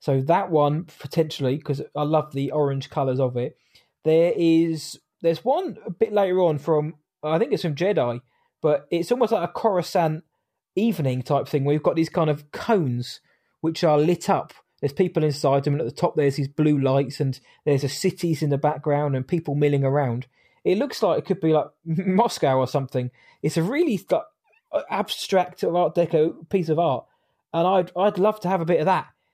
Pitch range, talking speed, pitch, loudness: 145-175 Hz, 200 wpm, 155 Hz, -23 LUFS